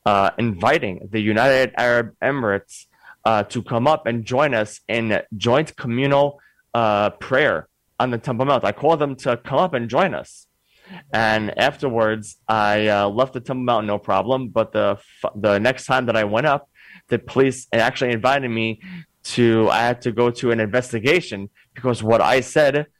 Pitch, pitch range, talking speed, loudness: 115 Hz, 110-130 Hz, 175 wpm, -20 LUFS